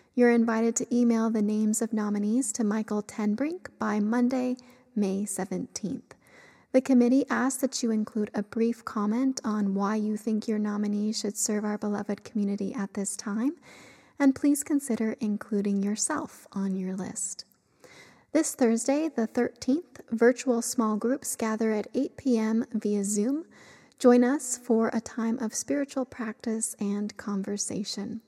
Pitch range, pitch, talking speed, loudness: 210-250 Hz, 225 Hz, 145 wpm, -28 LUFS